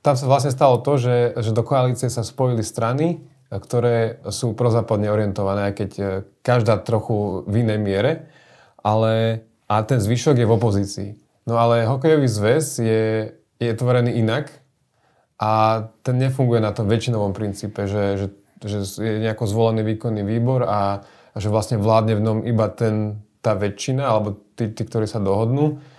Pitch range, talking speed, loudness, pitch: 105-125 Hz, 160 wpm, -20 LUFS, 115 Hz